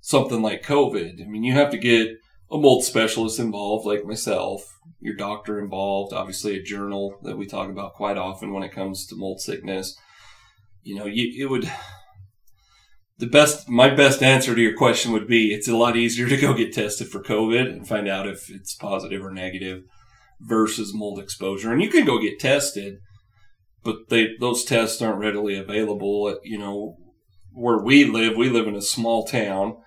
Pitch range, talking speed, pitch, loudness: 100-115 Hz, 190 wpm, 105 Hz, -21 LUFS